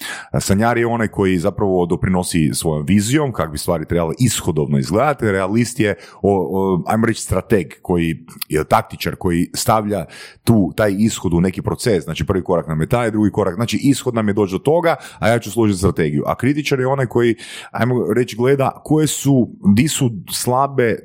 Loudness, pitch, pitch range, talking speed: -17 LUFS, 105 Hz, 90-120 Hz, 185 wpm